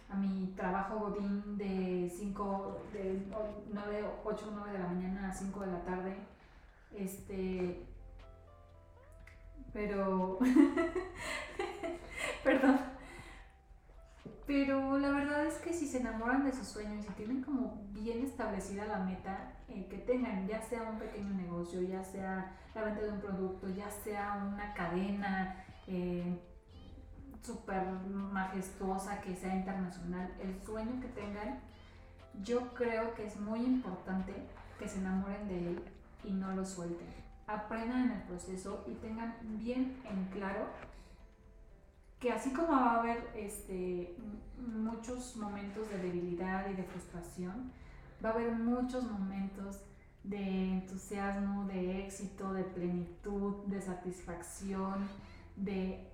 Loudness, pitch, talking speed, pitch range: -38 LUFS, 200 Hz, 130 wpm, 185-220 Hz